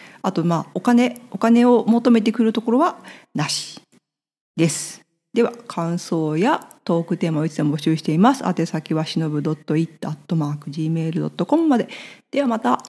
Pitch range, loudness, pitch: 160-235 Hz, -20 LUFS, 170 Hz